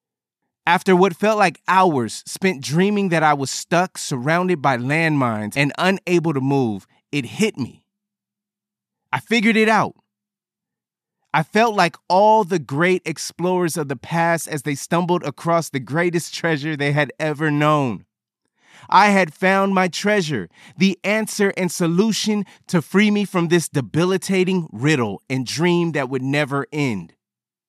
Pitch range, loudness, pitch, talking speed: 145-195 Hz, -19 LUFS, 175 Hz, 145 wpm